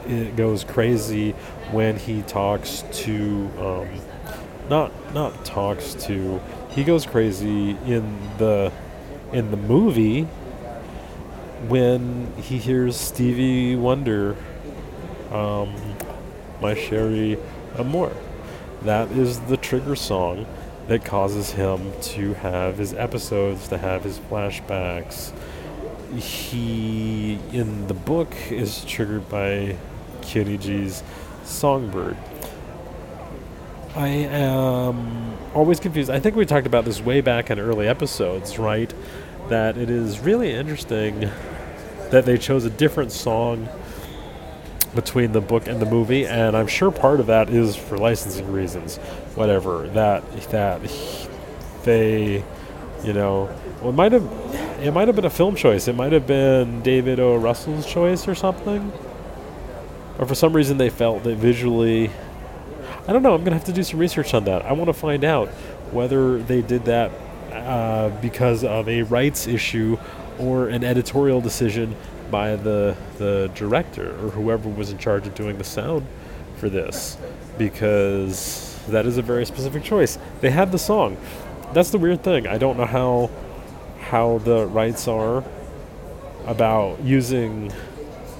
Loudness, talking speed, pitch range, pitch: -22 LUFS, 140 wpm, 100-130 Hz, 115 Hz